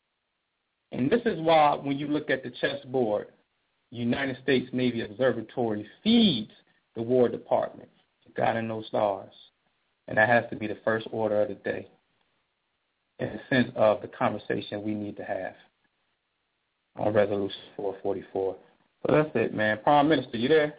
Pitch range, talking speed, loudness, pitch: 105-145 Hz, 165 wpm, -27 LUFS, 125 Hz